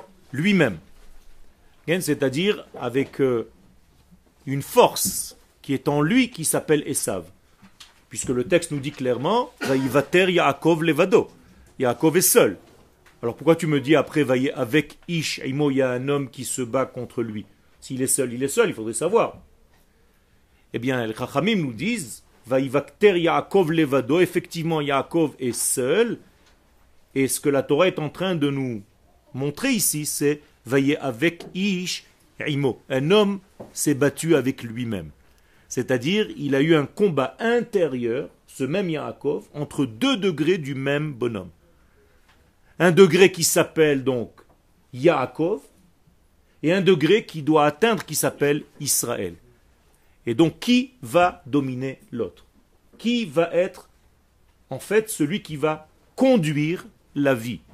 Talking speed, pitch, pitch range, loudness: 145 wpm, 145 Hz, 125-170 Hz, -22 LUFS